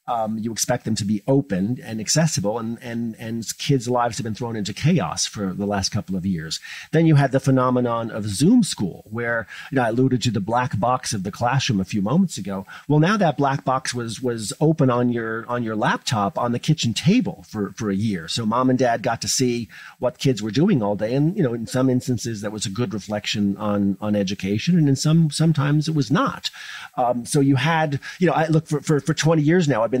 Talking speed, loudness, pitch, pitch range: 240 wpm, -21 LUFS, 120 Hz, 105-145 Hz